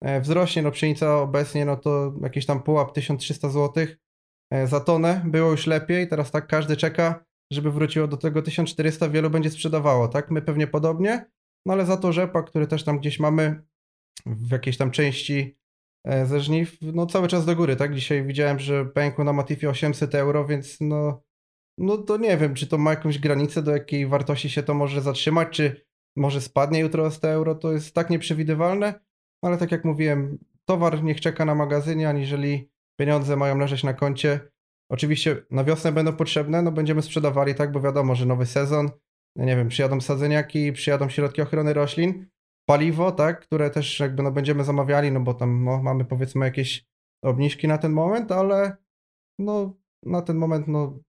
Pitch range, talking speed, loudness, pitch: 140-160 Hz, 175 wpm, -23 LUFS, 150 Hz